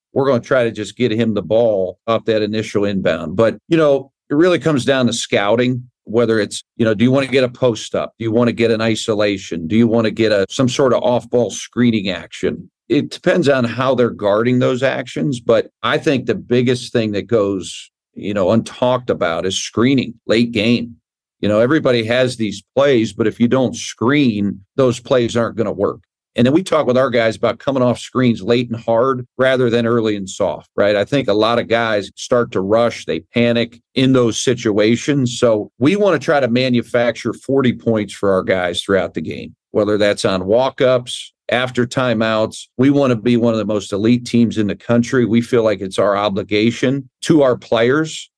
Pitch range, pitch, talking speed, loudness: 105-125 Hz, 115 Hz, 215 wpm, -16 LUFS